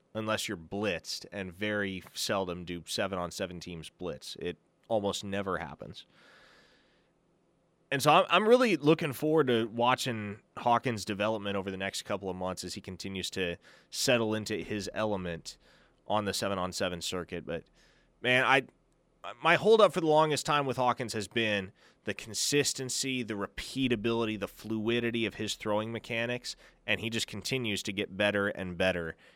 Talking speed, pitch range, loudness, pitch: 160 wpm, 95-125 Hz, -30 LUFS, 110 Hz